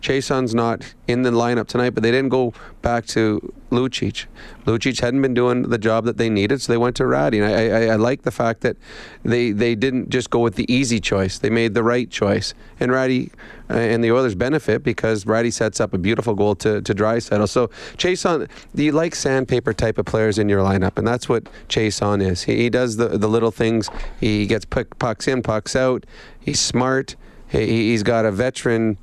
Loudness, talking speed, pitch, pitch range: -20 LUFS, 215 wpm, 115 Hz, 110-125 Hz